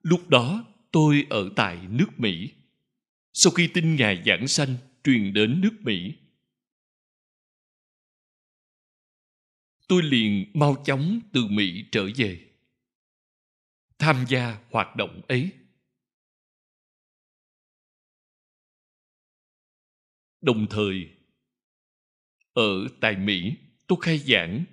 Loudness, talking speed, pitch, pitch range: -23 LUFS, 90 wpm, 135 Hz, 105-175 Hz